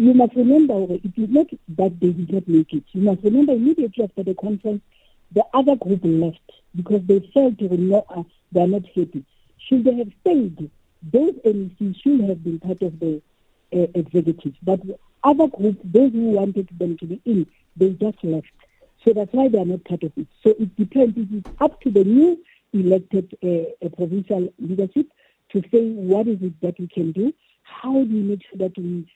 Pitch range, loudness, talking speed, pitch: 180-235 Hz, -20 LUFS, 205 wpm, 200 Hz